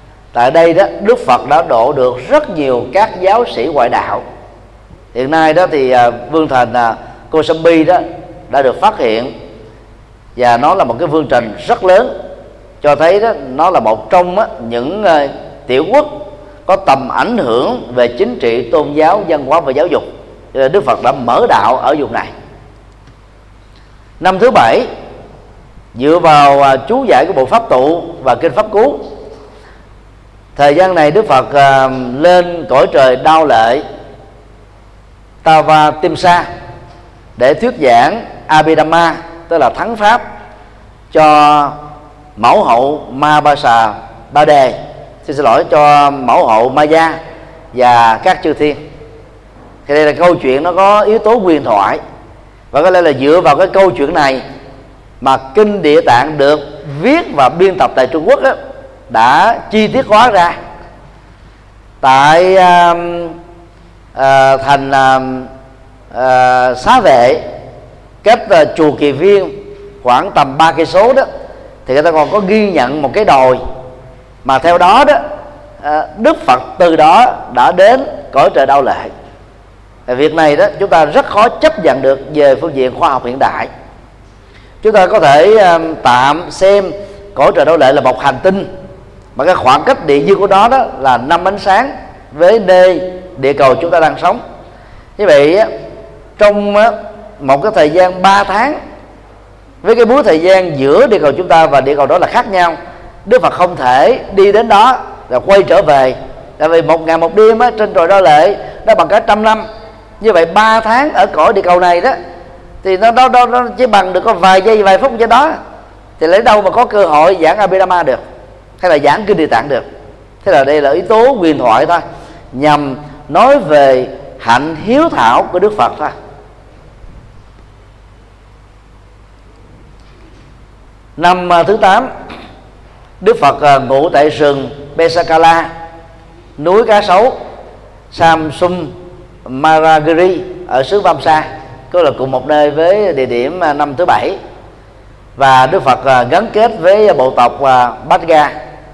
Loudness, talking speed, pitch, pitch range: -9 LUFS, 165 wpm, 150 Hz, 125-185 Hz